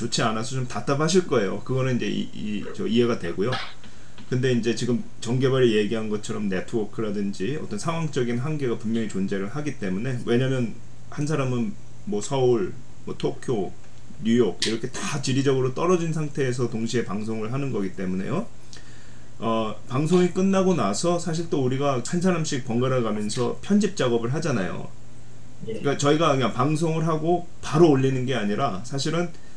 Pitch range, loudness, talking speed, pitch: 115-155 Hz, -25 LUFS, 355 characters per minute, 130 Hz